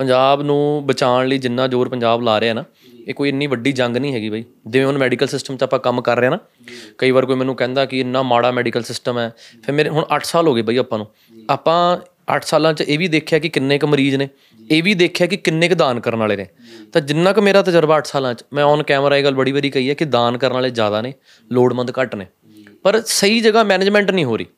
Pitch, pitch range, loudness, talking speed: 135 Hz, 120-150 Hz, -16 LUFS, 255 wpm